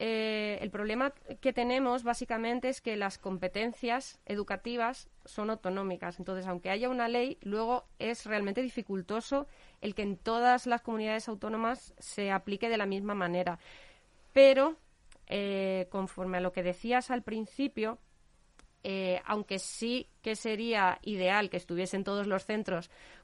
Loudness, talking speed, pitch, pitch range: -33 LUFS, 140 wpm, 215 Hz, 190-240 Hz